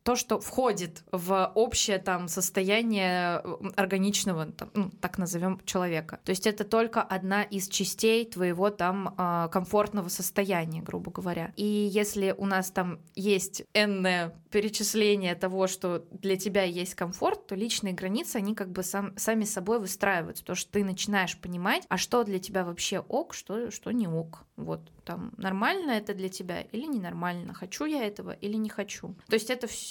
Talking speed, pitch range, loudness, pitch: 170 wpm, 185-210 Hz, -29 LUFS, 195 Hz